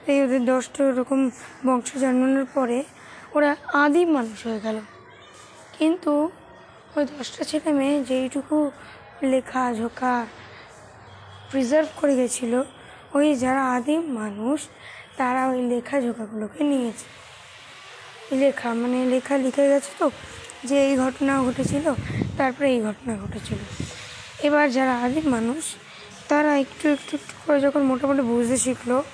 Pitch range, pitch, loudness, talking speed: 250-290 Hz, 265 Hz, -23 LUFS, 120 wpm